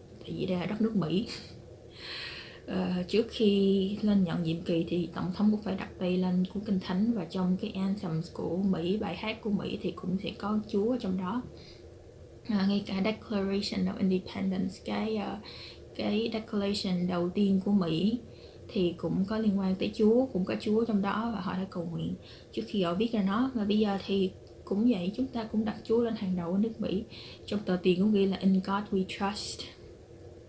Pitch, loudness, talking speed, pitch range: 195 Hz, -30 LUFS, 205 wpm, 185-215 Hz